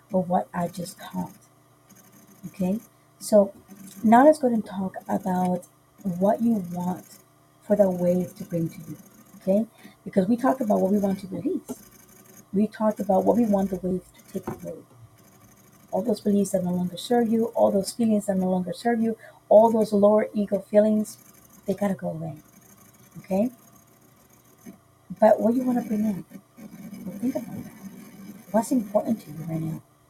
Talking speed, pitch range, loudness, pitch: 175 wpm, 180-215 Hz, -24 LUFS, 200 Hz